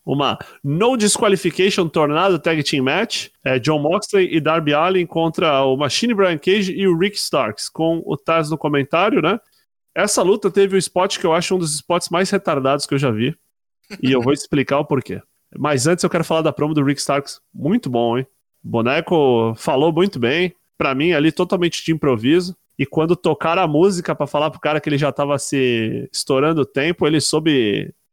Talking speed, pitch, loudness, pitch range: 200 wpm, 160 Hz, -18 LUFS, 140-180 Hz